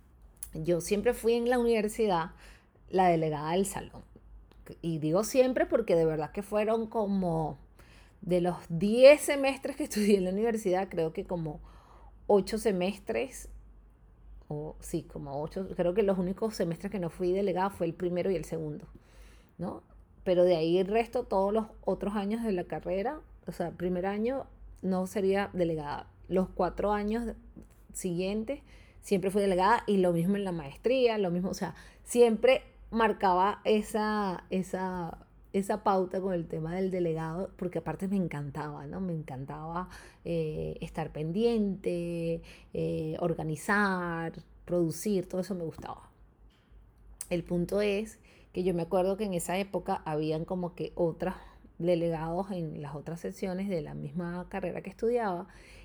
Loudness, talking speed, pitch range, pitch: -31 LUFS, 155 wpm, 165-205 Hz, 185 Hz